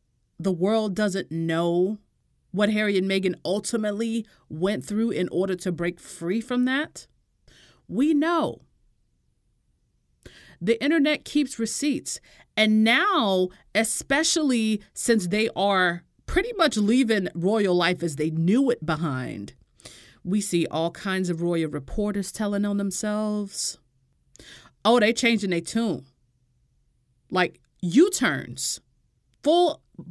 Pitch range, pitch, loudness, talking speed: 175-230 Hz, 200 Hz, -24 LUFS, 115 wpm